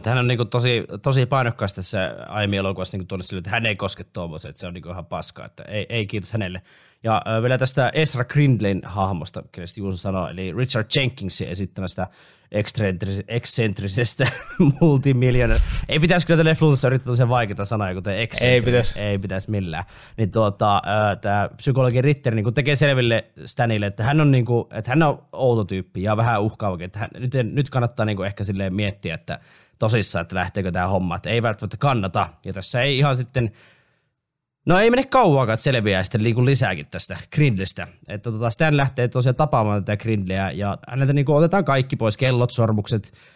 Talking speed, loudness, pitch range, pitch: 160 wpm, -21 LUFS, 100-130 Hz, 110 Hz